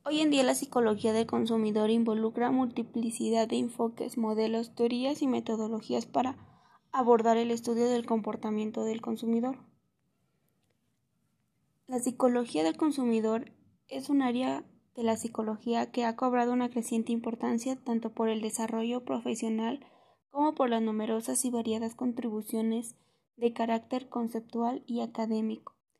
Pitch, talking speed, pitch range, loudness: 235 Hz, 130 wpm, 225-245 Hz, -31 LUFS